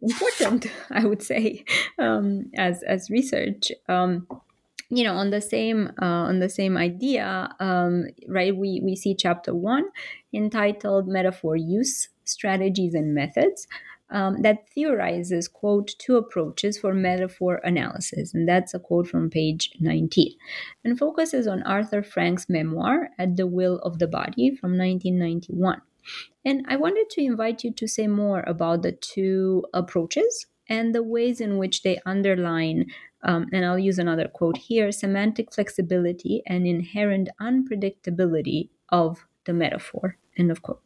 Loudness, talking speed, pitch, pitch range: -24 LUFS, 145 wpm, 190 Hz, 180-225 Hz